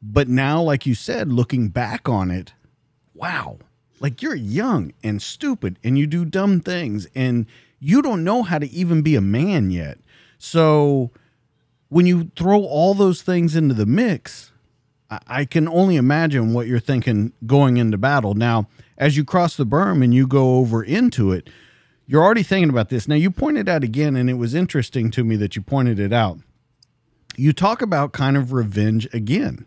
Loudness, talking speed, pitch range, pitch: -19 LUFS, 185 wpm, 120-165 Hz, 135 Hz